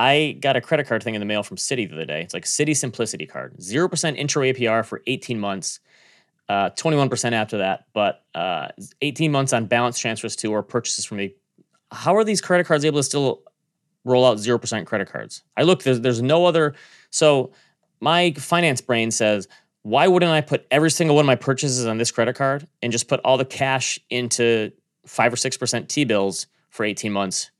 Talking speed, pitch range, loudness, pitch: 205 wpm, 115-150 Hz, -21 LUFS, 125 Hz